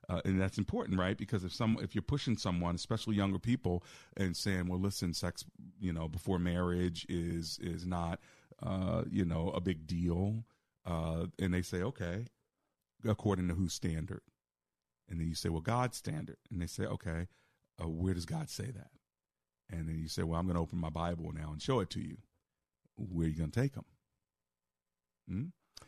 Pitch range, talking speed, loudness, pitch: 80-100 Hz, 195 wpm, -37 LUFS, 90 Hz